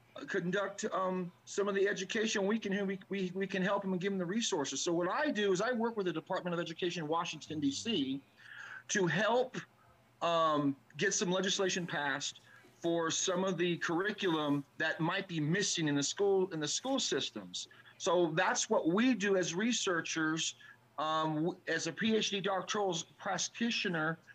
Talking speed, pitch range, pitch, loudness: 175 wpm, 160-200 Hz, 185 Hz, -34 LUFS